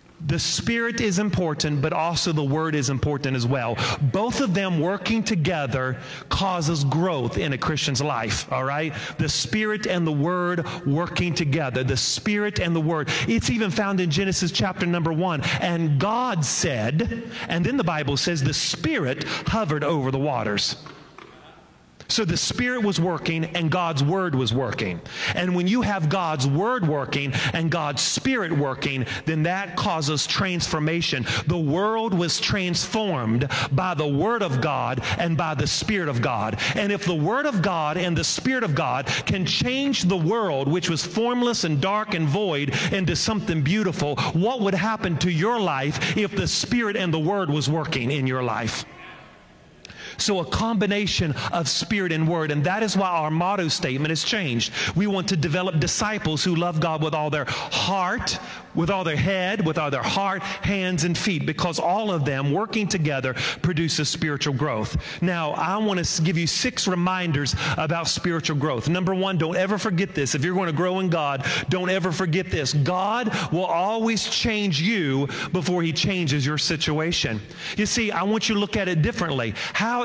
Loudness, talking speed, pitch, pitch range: -23 LUFS, 180 wpm, 165 Hz, 145-190 Hz